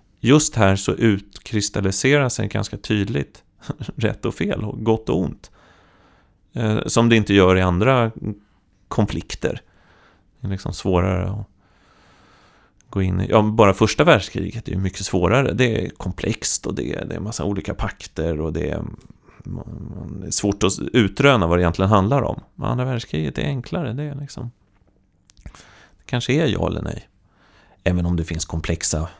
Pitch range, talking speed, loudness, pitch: 95-115 Hz, 160 wpm, -20 LUFS, 100 Hz